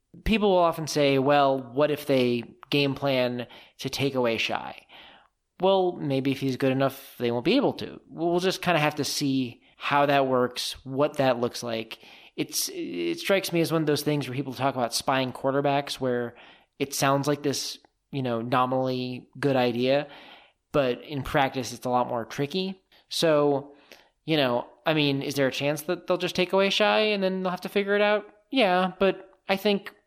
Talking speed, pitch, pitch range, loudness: 195 wpm, 140 Hz, 130-180 Hz, -26 LUFS